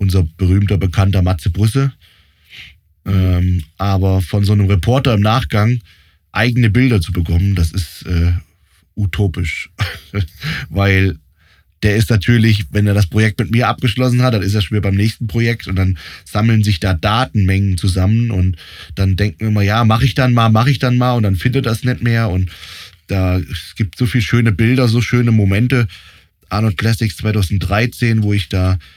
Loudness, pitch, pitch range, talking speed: -15 LUFS, 100 Hz, 95-115 Hz, 180 wpm